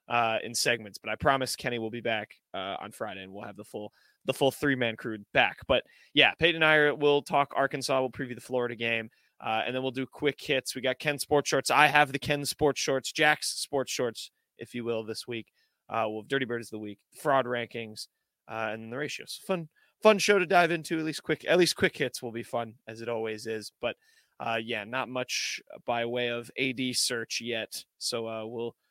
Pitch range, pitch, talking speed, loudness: 115-145 Hz, 125 Hz, 230 wpm, -28 LUFS